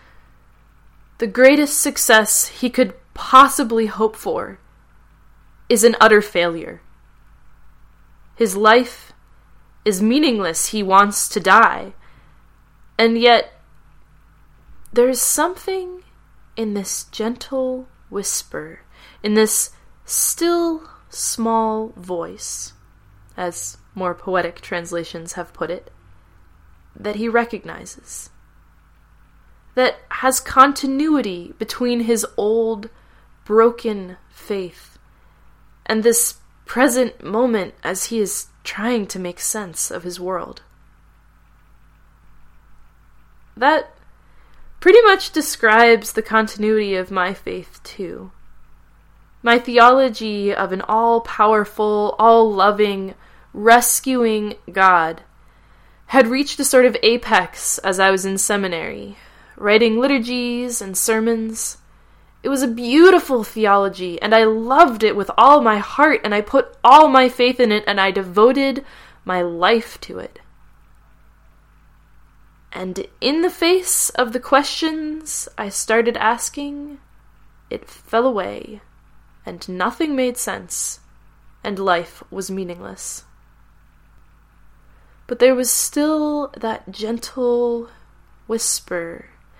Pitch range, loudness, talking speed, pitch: 190-250 Hz, -17 LUFS, 105 wpm, 220 Hz